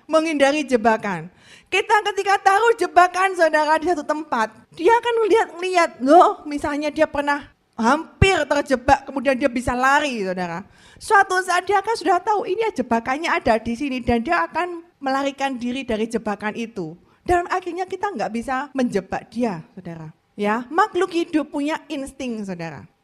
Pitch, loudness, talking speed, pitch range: 290 Hz, -20 LUFS, 150 wpm, 235-355 Hz